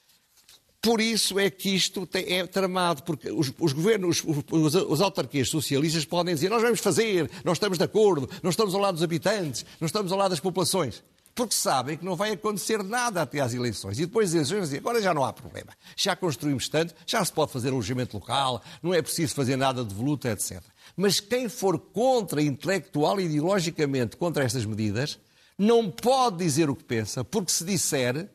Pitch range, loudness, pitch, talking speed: 145-200 Hz, -26 LUFS, 175 Hz, 200 wpm